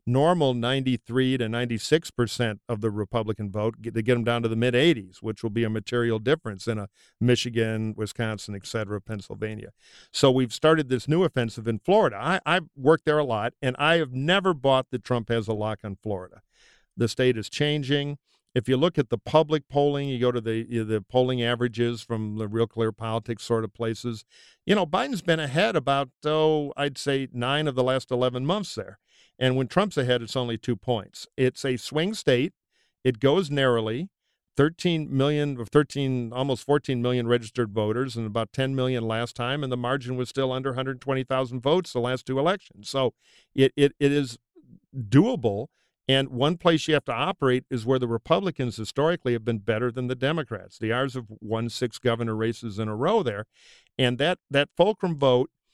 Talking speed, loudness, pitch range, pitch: 195 wpm, -25 LUFS, 115-145 Hz, 125 Hz